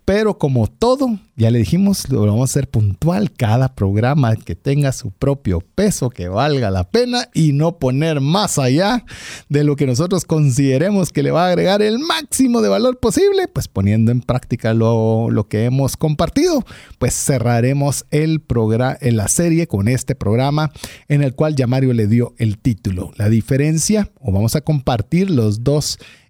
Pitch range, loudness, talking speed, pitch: 115-170 Hz, -16 LUFS, 180 wpm, 140 Hz